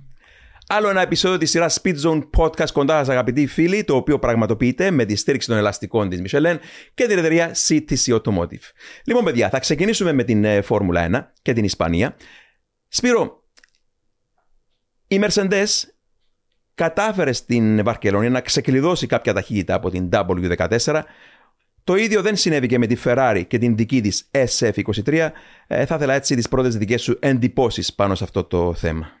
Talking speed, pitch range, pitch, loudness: 160 wpm, 105-160 Hz, 125 Hz, -19 LUFS